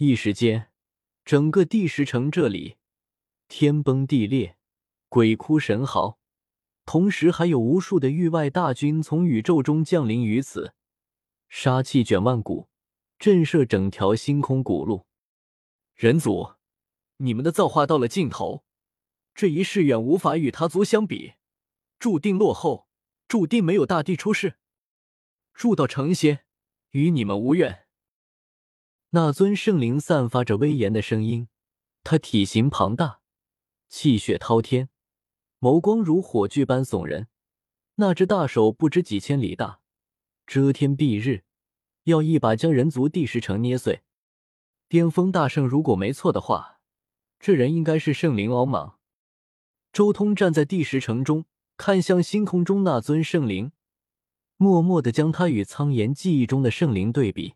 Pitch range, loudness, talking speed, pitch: 120-170 Hz, -22 LUFS, 205 characters per minute, 145 Hz